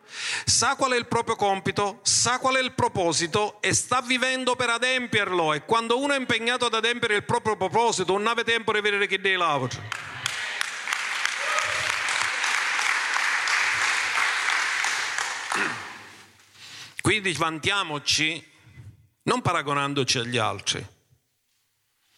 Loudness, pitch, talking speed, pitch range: -24 LUFS, 205 Hz, 110 wpm, 155-240 Hz